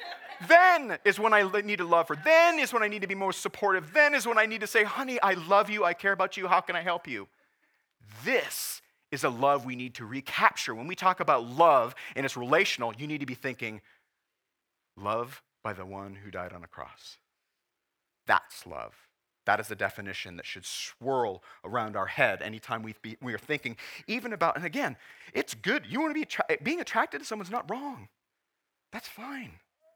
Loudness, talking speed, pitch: -27 LUFS, 205 wpm, 180 Hz